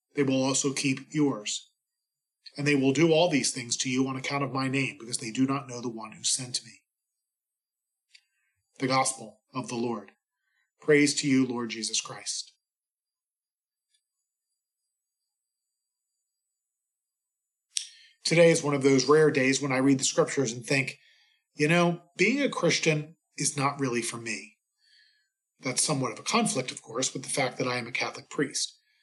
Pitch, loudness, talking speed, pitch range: 135 Hz, -27 LUFS, 165 wpm, 130-155 Hz